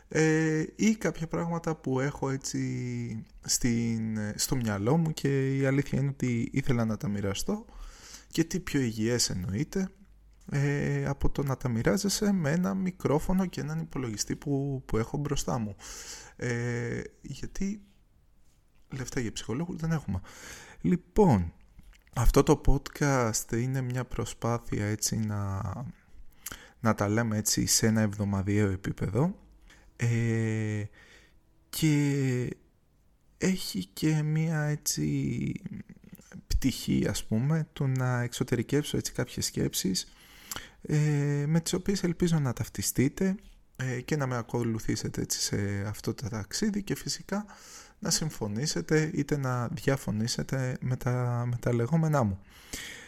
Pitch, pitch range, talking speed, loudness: 135 Hz, 115-155 Hz, 120 wpm, -30 LUFS